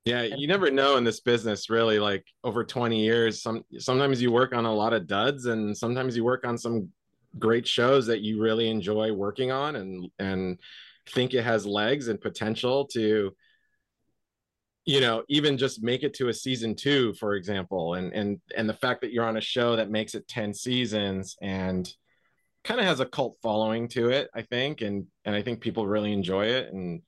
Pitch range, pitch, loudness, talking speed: 105-125 Hz, 115 Hz, -27 LUFS, 200 wpm